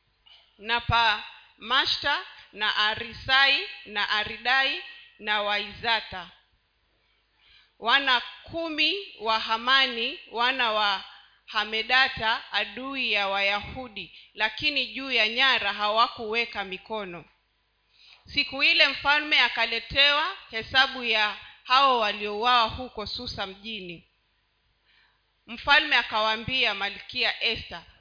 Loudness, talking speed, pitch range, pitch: -24 LUFS, 85 wpm, 210-265 Hz, 225 Hz